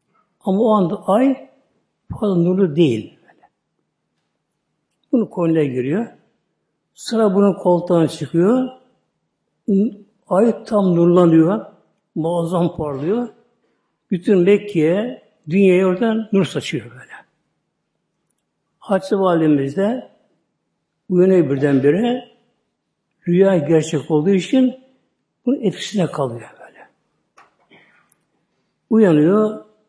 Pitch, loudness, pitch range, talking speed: 195 Hz, -17 LUFS, 170-215 Hz, 80 wpm